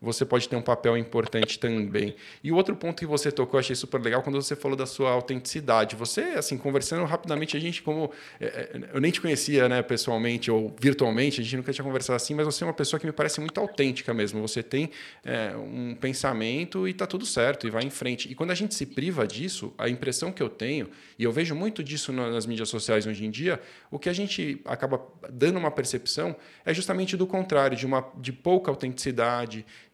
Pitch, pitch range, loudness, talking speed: 135 Hz, 120-155 Hz, -28 LUFS, 220 wpm